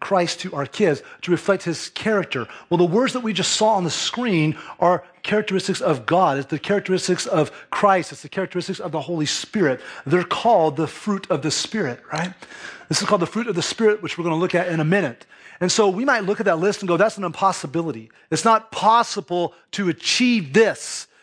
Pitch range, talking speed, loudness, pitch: 165-205 Hz, 220 wpm, -21 LUFS, 180 Hz